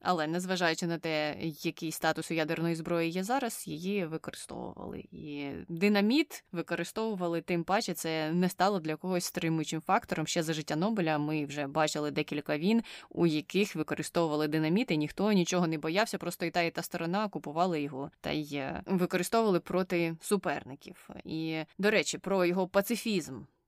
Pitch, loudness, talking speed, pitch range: 170 Hz, -31 LUFS, 155 wpm, 155-185 Hz